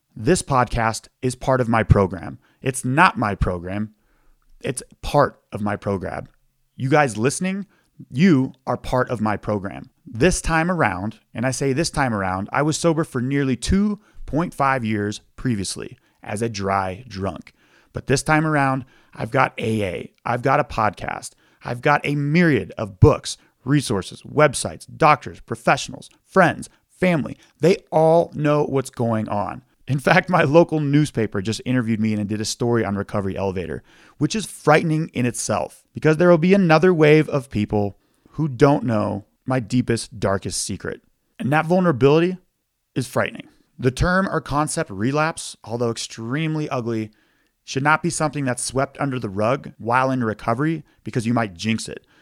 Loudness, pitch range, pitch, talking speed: -21 LUFS, 110-150 Hz, 130 Hz, 160 wpm